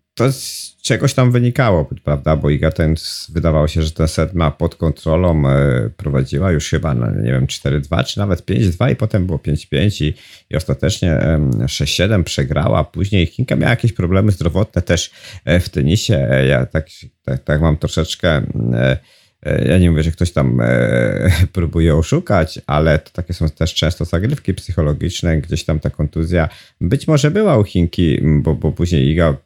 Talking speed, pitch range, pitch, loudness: 160 wpm, 75-90 Hz, 80 Hz, -16 LUFS